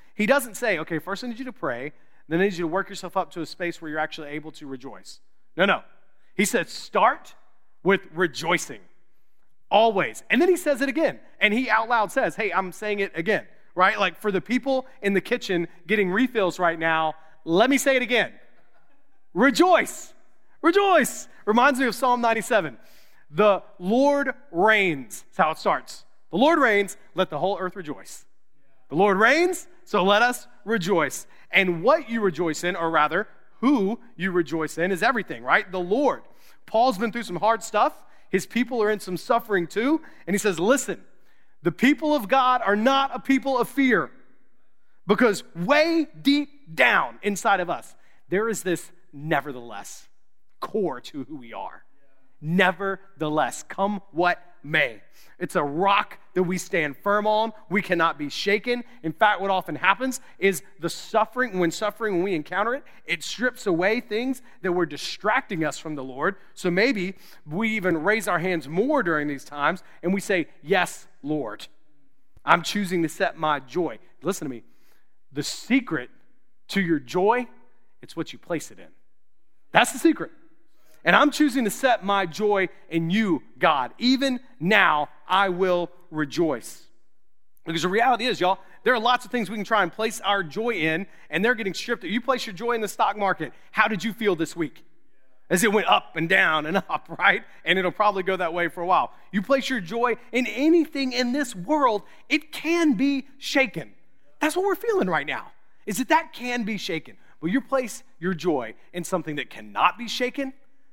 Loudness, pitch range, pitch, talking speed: -23 LUFS, 175-245 Hz, 200 Hz, 185 wpm